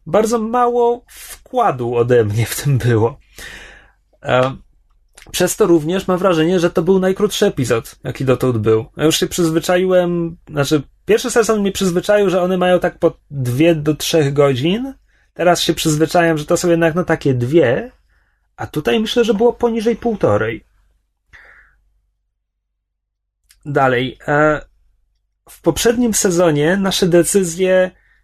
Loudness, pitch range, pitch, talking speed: -16 LUFS, 130-190 Hz, 170 Hz, 130 wpm